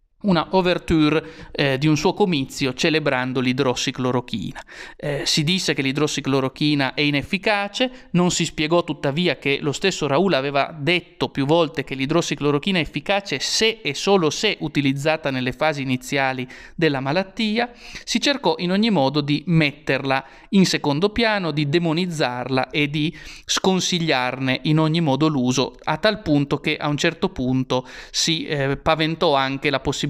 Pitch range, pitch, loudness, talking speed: 135-175 Hz, 155 Hz, -21 LUFS, 150 wpm